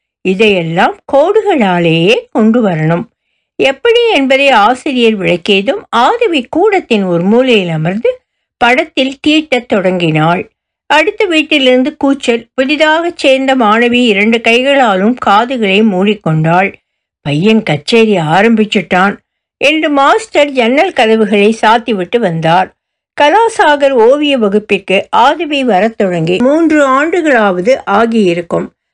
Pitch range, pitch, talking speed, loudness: 200-295 Hz, 235 Hz, 90 wpm, -9 LUFS